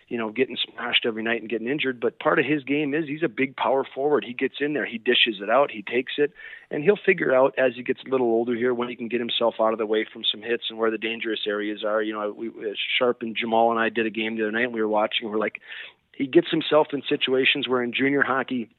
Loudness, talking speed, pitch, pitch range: -24 LUFS, 285 wpm, 120 Hz, 115-135 Hz